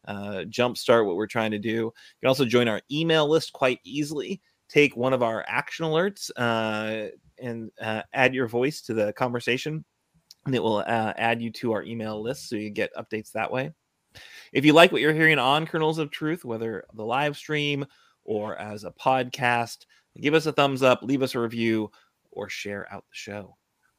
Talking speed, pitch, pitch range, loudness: 200 wpm, 120 Hz, 110-145 Hz, -25 LUFS